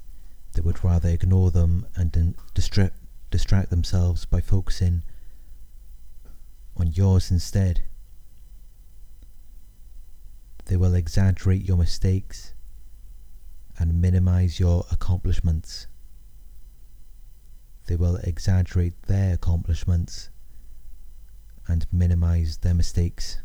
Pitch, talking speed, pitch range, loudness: 90 Hz, 80 wpm, 85-95 Hz, -24 LUFS